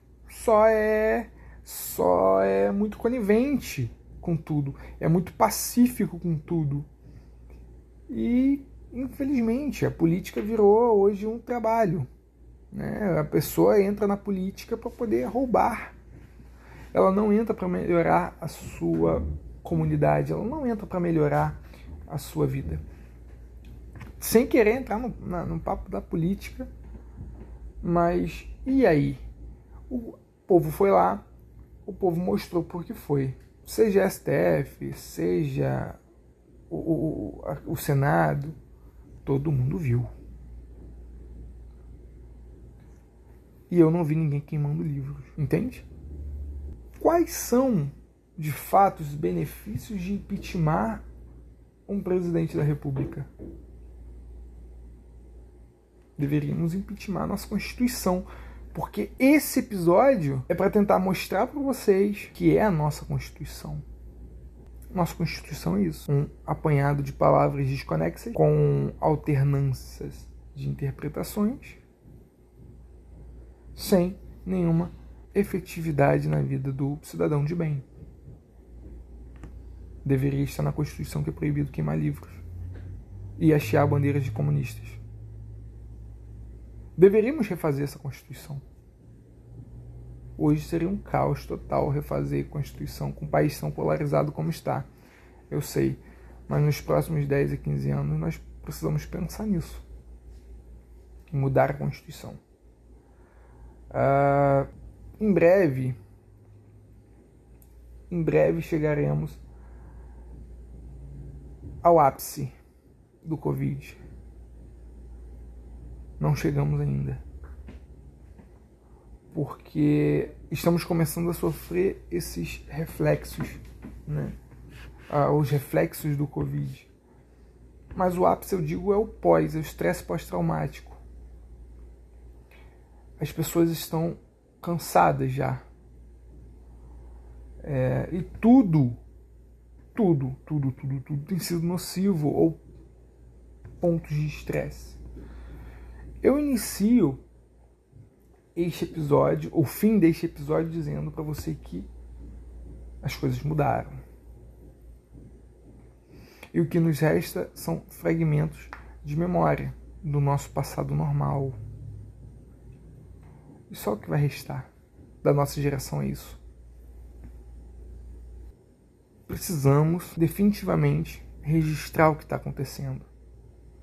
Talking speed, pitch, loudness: 100 wpm, 130 Hz, -26 LUFS